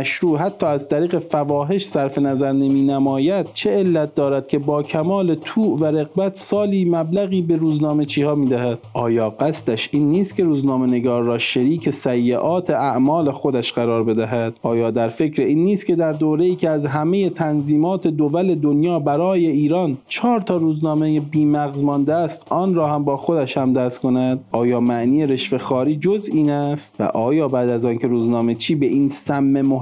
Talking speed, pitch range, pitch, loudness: 175 wpm, 130-165 Hz, 150 Hz, -19 LUFS